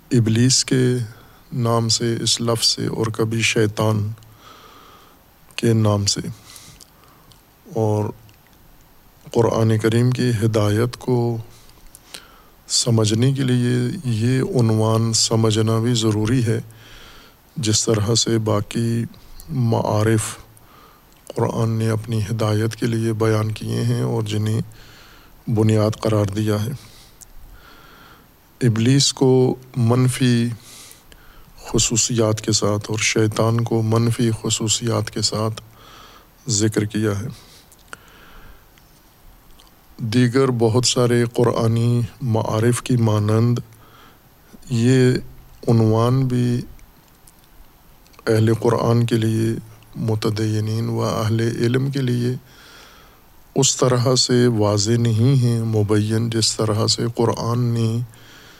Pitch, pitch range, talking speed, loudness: 115 Hz, 110-120 Hz, 100 wpm, -19 LUFS